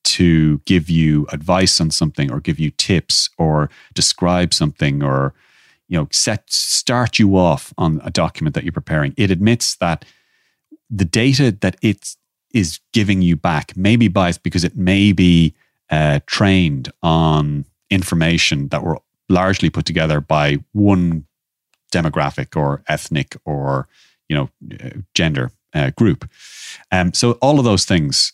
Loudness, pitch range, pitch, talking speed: -16 LUFS, 75-100 Hz, 90 Hz, 150 wpm